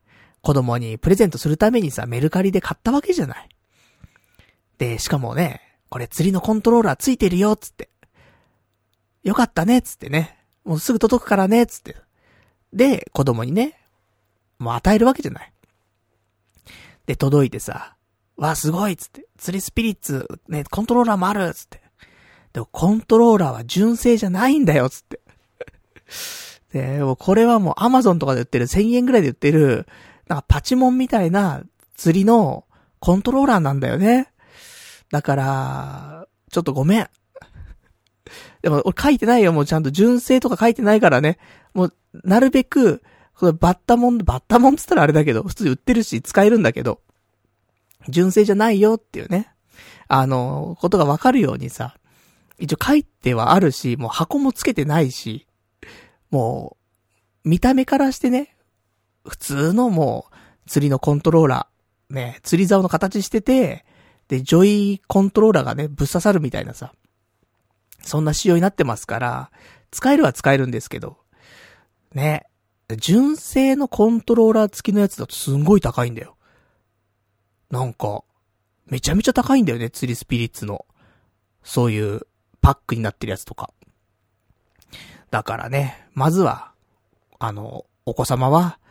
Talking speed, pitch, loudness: 325 characters per minute, 165 Hz, -18 LUFS